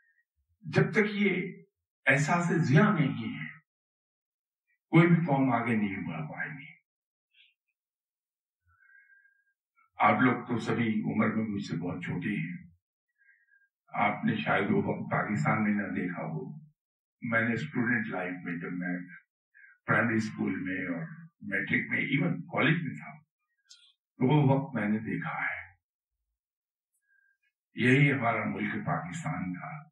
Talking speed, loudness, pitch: 130 wpm, -29 LUFS, 135 Hz